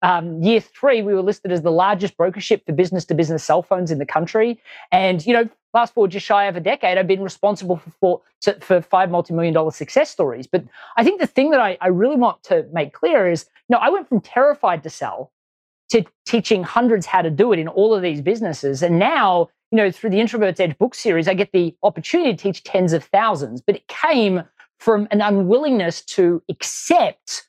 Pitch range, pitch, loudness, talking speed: 175-230 Hz, 200 Hz, -18 LUFS, 220 wpm